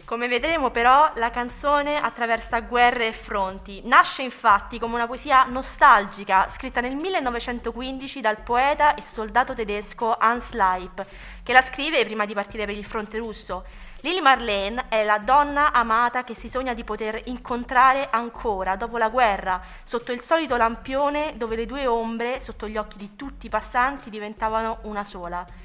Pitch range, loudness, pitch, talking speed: 215-260 Hz, -22 LUFS, 235 Hz, 160 wpm